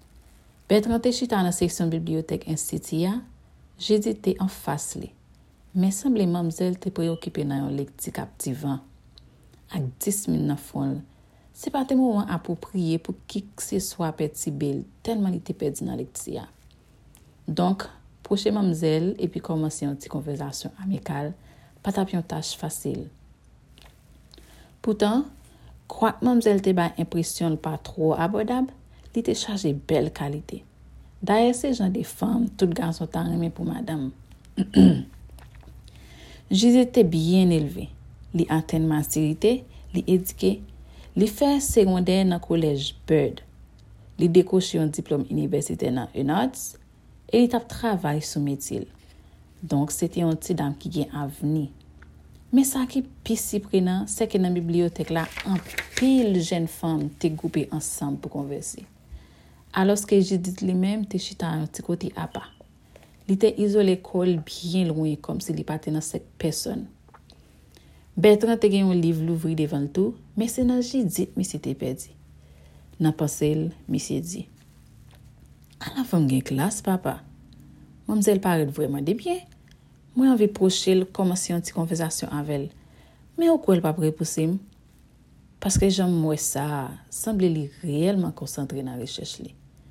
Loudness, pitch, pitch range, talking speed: -25 LUFS, 170 Hz, 145-195 Hz, 150 wpm